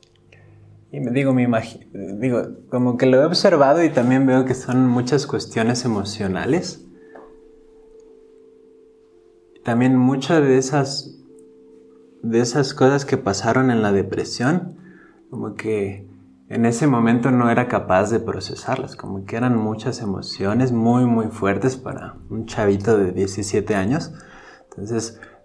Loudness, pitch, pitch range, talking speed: -19 LUFS, 120 Hz, 105-135 Hz, 130 wpm